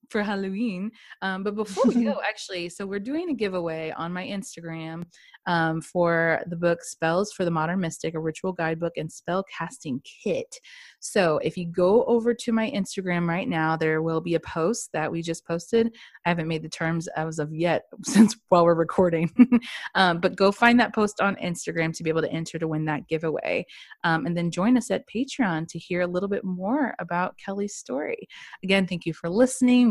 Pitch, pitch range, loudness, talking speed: 180 Hz, 165-210 Hz, -25 LUFS, 205 wpm